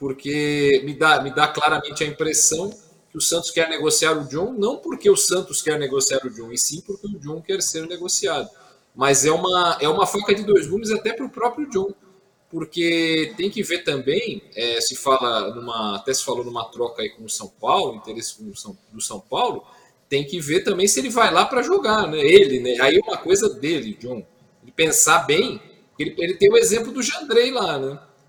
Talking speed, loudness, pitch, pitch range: 215 wpm, -20 LUFS, 160 Hz, 140-205 Hz